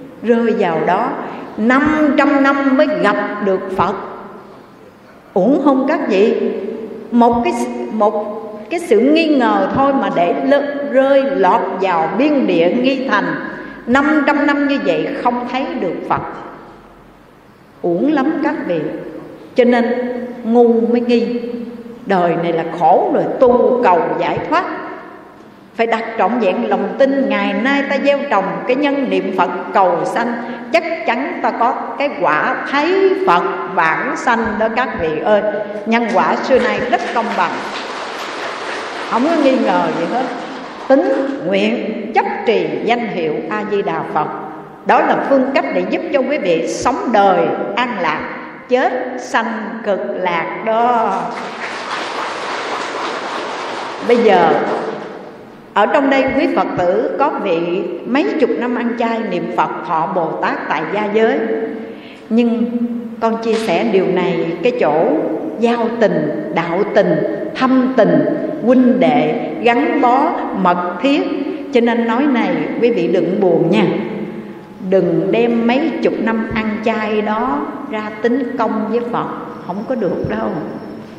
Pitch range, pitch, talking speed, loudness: 215-275 Hz, 240 Hz, 150 wpm, -16 LUFS